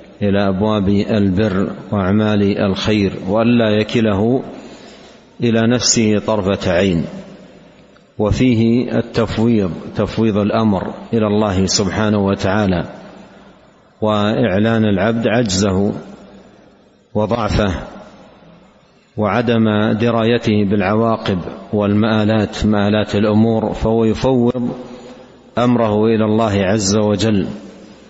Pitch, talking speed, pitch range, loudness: 105 Hz, 75 wpm, 105-115 Hz, -16 LUFS